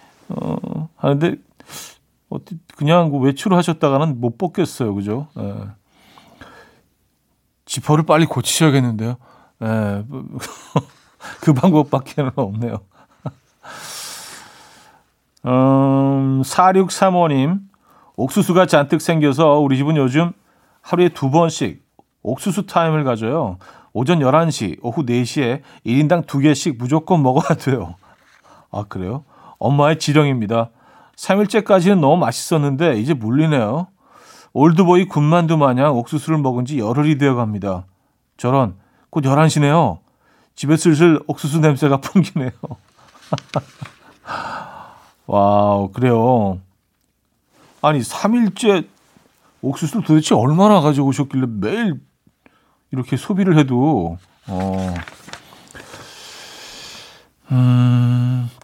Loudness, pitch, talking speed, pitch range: -17 LUFS, 145 Hz, 215 characters per minute, 125-165 Hz